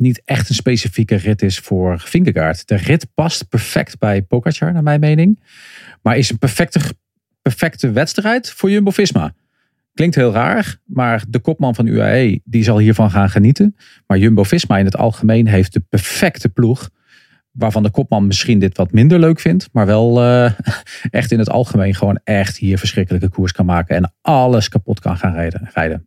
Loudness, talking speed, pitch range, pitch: -14 LUFS, 175 wpm, 100-140 Hz, 115 Hz